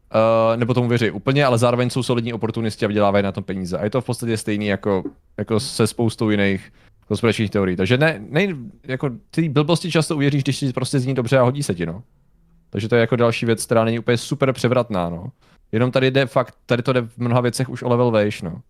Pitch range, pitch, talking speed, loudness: 105-130 Hz, 120 Hz, 235 wpm, -20 LUFS